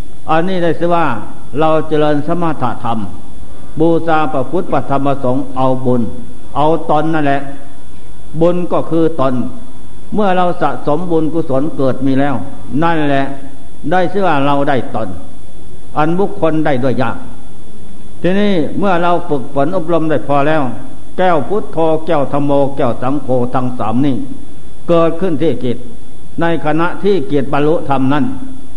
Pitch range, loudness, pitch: 130-165 Hz, -15 LUFS, 145 Hz